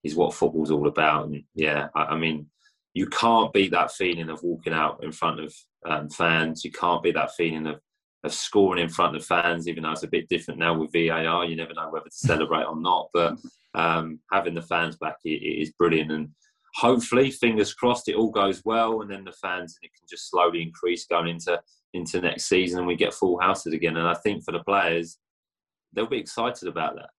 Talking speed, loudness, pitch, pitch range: 220 wpm, -25 LUFS, 85 Hz, 80-90 Hz